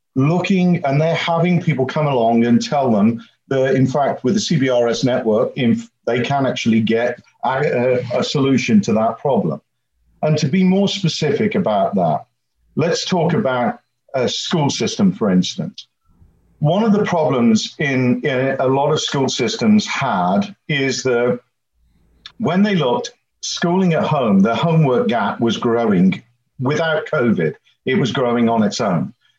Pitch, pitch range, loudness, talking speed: 150 Hz, 125-195 Hz, -17 LUFS, 155 wpm